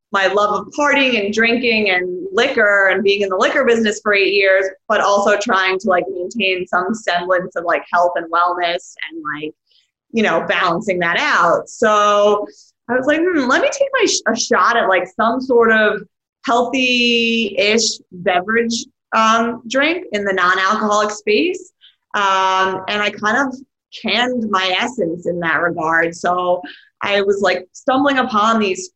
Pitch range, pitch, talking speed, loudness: 185-235 Hz, 205 Hz, 165 wpm, -16 LUFS